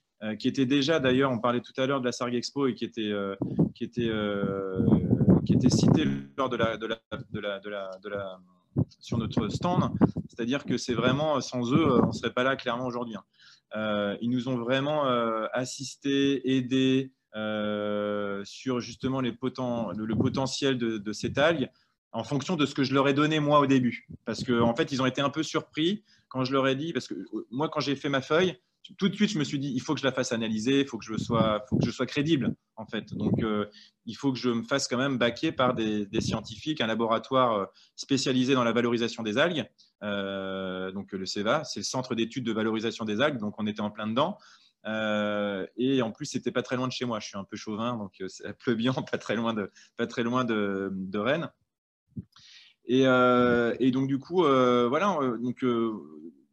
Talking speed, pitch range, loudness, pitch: 210 wpm, 110-135 Hz, -28 LUFS, 120 Hz